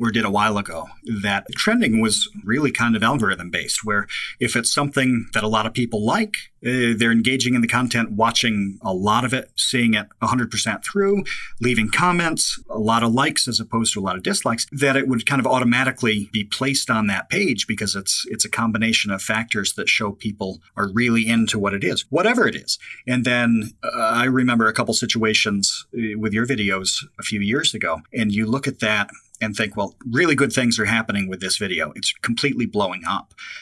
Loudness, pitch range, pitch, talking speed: -20 LUFS, 110-125 Hz, 115 Hz, 205 wpm